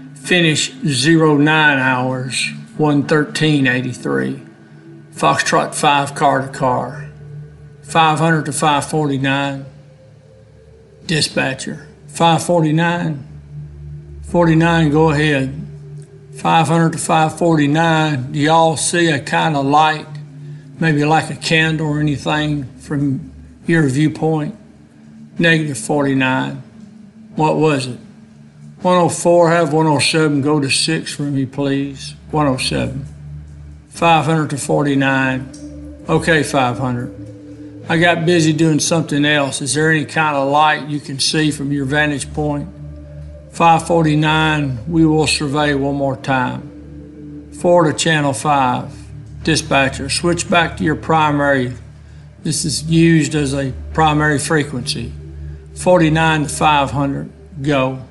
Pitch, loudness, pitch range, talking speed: 145 Hz, -15 LUFS, 135-160 Hz, 105 wpm